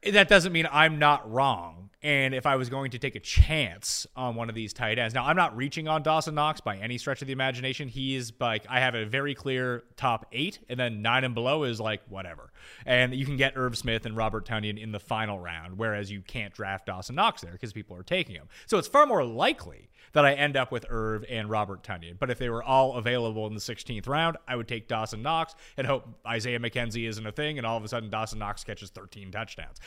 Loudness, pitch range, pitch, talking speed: -28 LUFS, 110-135 Hz, 120 Hz, 245 wpm